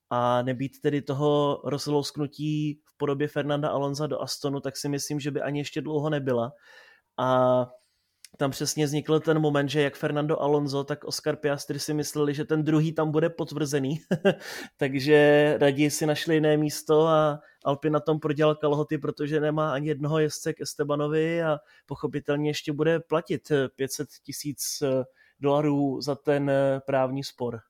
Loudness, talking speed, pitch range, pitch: -26 LUFS, 155 wpm, 140-150 Hz, 150 Hz